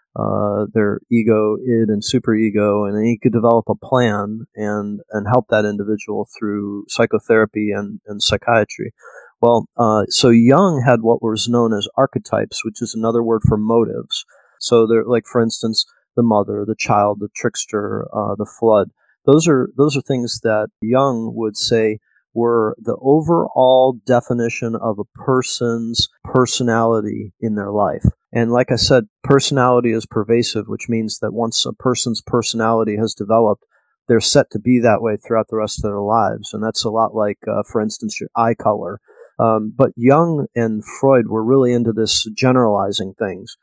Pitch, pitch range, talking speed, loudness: 115 Hz, 110-125 Hz, 170 wpm, -17 LUFS